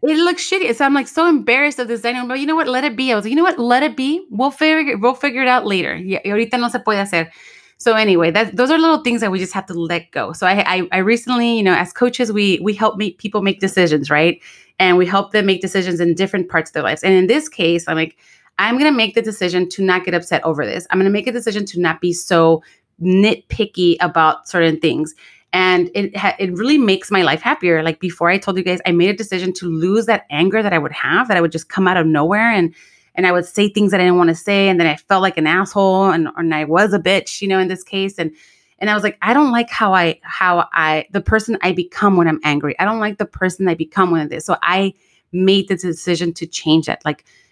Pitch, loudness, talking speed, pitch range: 190 Hz, -16 LUFS, 275 wpm, 175-220 Hz